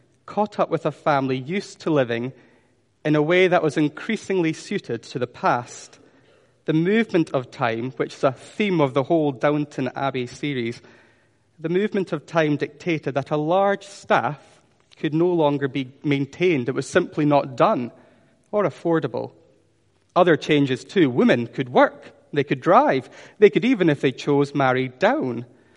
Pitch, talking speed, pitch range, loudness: 150 Hz, 165 wpm, 130-170 Hz, -22 LUFS